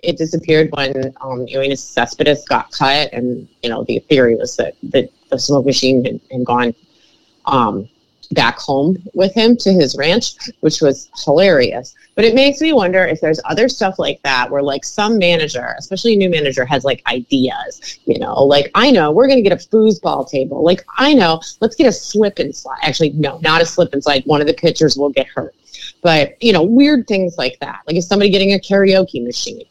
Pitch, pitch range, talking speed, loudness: 160 Hz, 140-200 Hz, 210 wpm, -14 LUFS